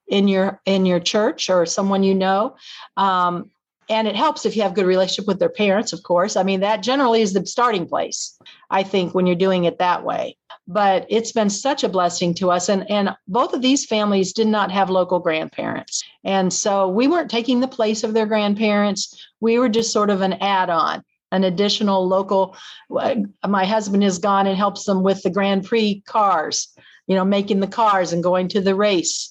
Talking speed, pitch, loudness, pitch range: 210 wpm, 200 Hz, -19 LUFS, 190-220 Hz